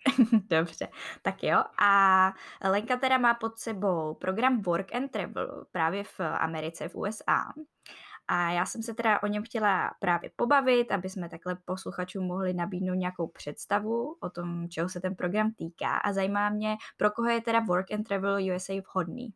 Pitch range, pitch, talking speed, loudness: 180-220 Hz, 195 Hz, 170 wpm, -29 LUFS